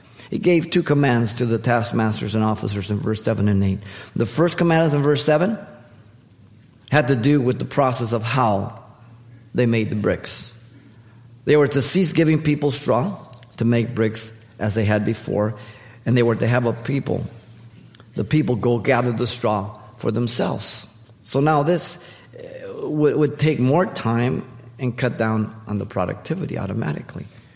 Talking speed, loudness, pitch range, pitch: 165 wpm, -20 LUFS, 110-140 Hz, 120 Hz